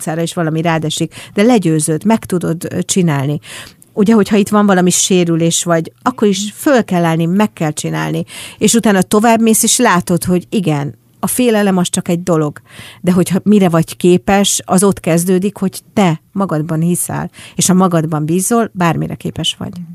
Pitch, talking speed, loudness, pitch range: 180 Hz, 165 wpm, -13 LUFS, 160-205 Hz